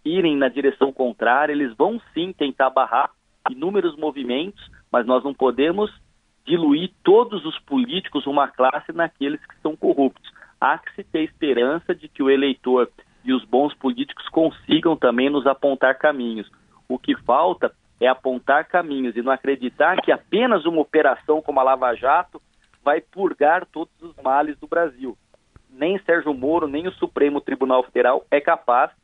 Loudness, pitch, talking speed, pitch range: -21 LUFS, 145 Hz, 160 wpm, 135-170 Hz